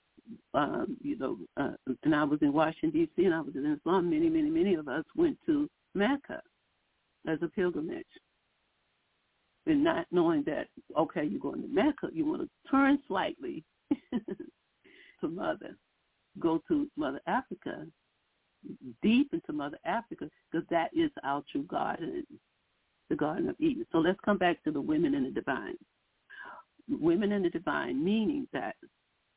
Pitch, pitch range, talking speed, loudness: 305 Hz, 205-330 Hz, 155 wpm, -31 LUFS